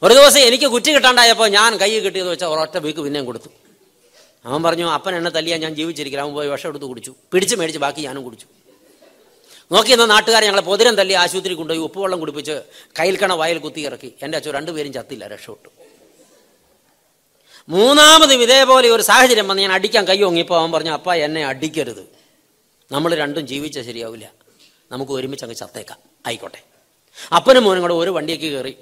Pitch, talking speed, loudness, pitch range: 170 Hz, 165 wpm, -14 LUFS, 150-215 Hz